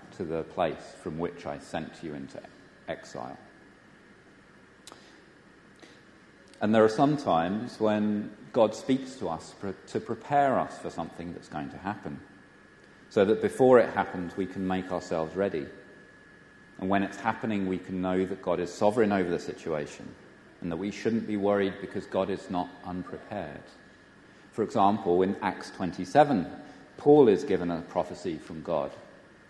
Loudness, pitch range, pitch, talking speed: -28 LUFS, 90-105 Hz, 95 Hz, 155 wpm